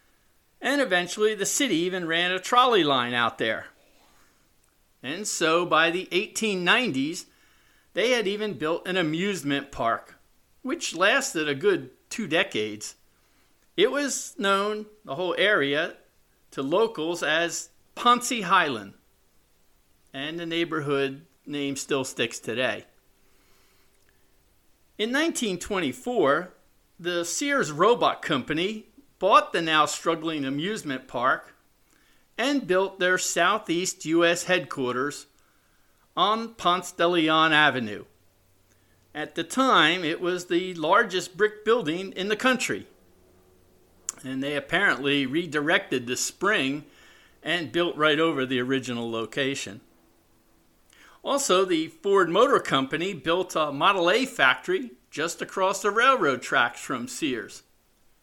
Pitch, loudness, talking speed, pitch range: 170 Hz, -24 LUFS, 115 wpm, 135-210 Hz